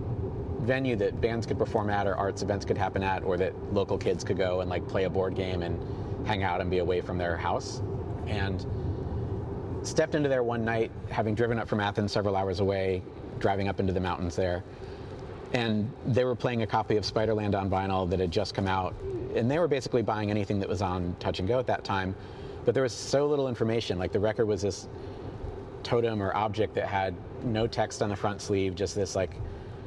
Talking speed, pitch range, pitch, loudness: 215 wpm, 95-115 Hz, 100 Hz, -29 LUFS